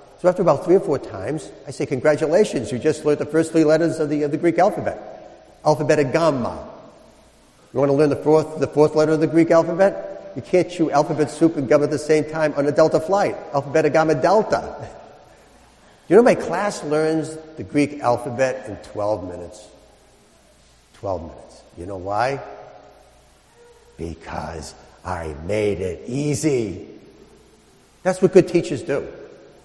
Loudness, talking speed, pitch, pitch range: -20 LUFS, 170 wpm, 150 Hz, 130-160 Hz